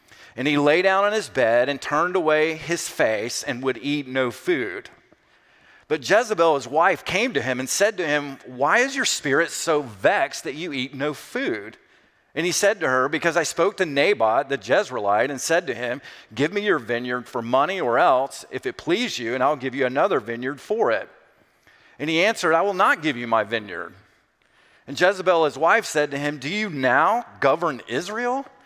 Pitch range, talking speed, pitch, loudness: 130-185 Hz, 205 wpm, 150 Hz, -22 LUFS